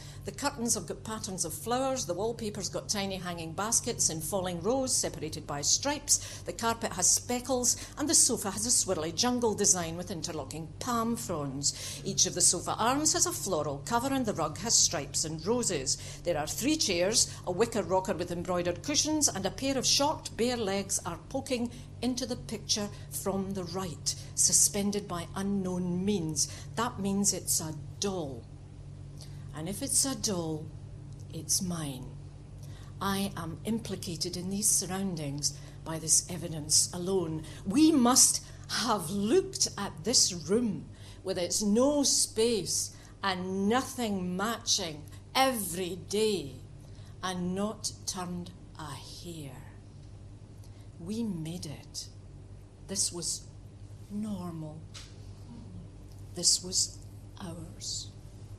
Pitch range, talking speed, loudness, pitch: 130-205 Hz, 135 wpm, -29 LUFS, 175 Hz